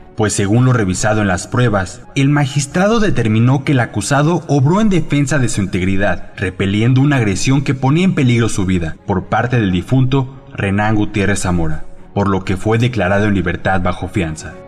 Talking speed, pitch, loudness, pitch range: 180 wpm, 105 Hz, -15 LUFS, 95-135 Hz